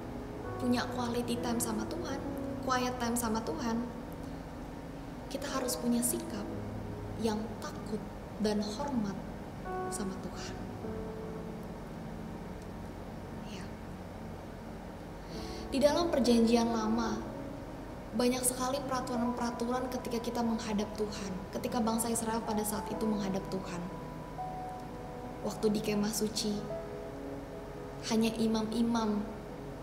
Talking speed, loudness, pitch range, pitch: 90 wpm, -35 LUFS, 215-240 Hz, 225 Hz